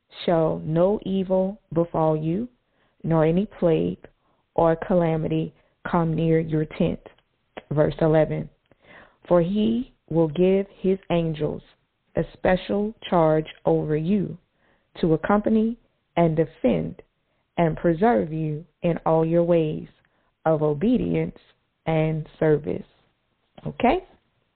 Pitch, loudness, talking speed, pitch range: 165 Hz, -23 LUFS, 105 wpm, 155-190 Hz